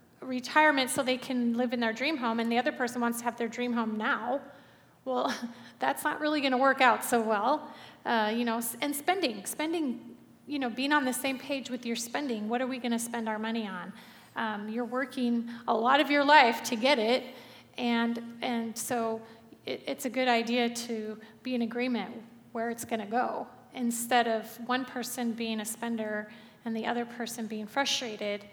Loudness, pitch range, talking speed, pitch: -30 LUFS, 230-255 Hz, 200 wpm, 240 Hz